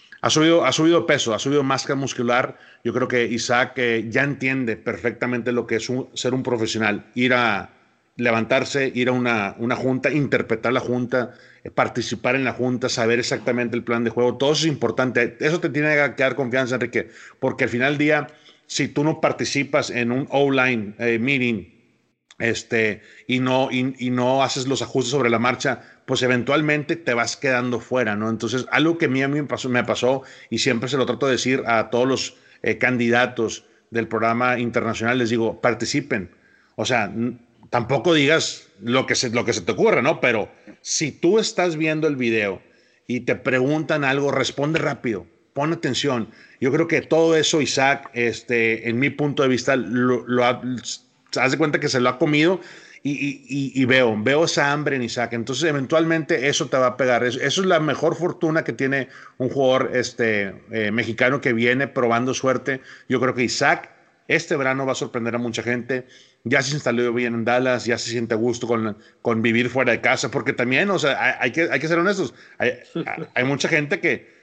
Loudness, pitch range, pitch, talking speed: -21 LUFS, 120-140 Hz, 125 Hz, 205 wpm